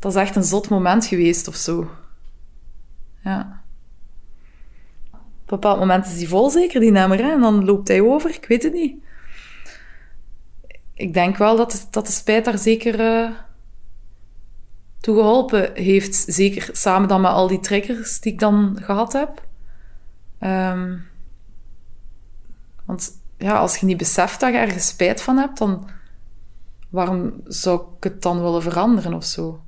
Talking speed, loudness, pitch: 160 wpm, -18 LUFS, 185 Hz